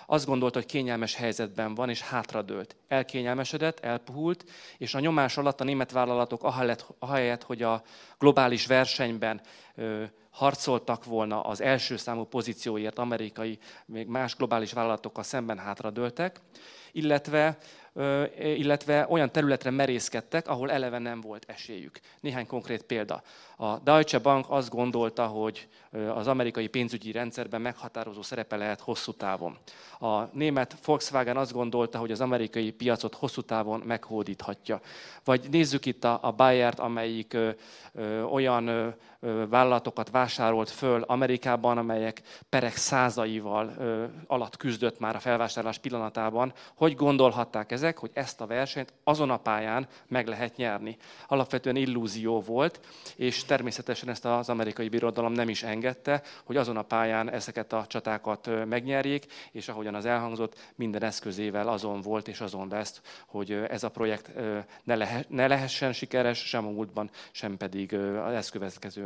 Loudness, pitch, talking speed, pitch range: -29 LUFS, 120 Hz, 130 wpm, 110-130 Hz